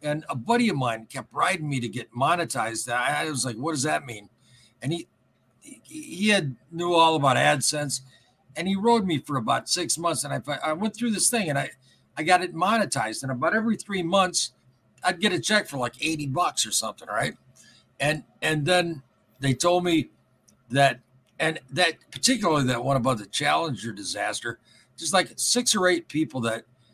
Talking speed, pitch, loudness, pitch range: 190 wpm, 150 Hz, -25 LUFS, 125-180 Hz